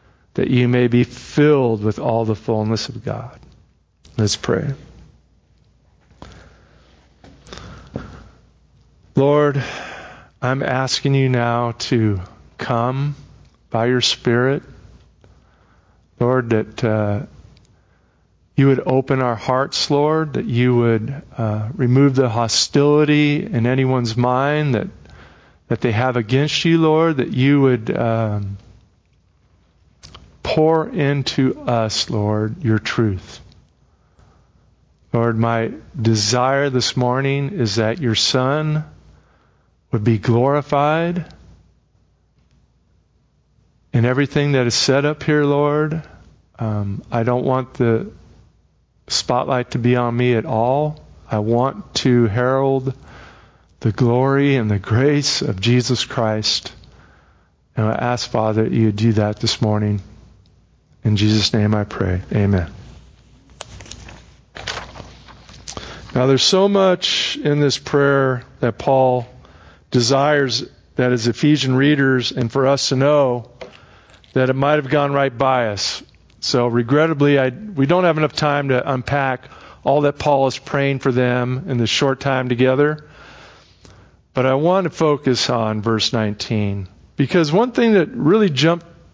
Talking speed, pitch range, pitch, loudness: 125 wpm, 110-140 Hz, 125 Hz, -18 LUFS